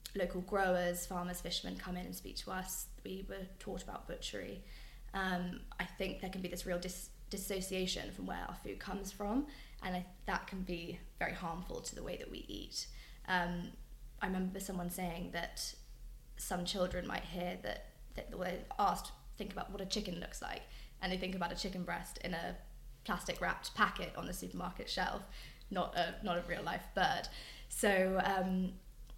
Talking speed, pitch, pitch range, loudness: 190 wpm, 185 Hz, 175-190 Hz, -40 LUFS